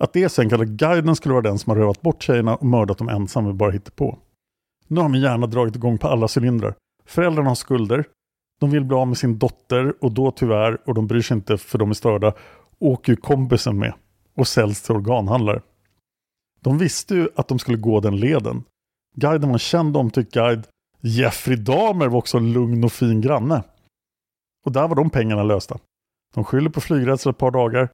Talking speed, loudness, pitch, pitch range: 210 wpm, -20 LUFS, 125 Hz, 110-135 Hz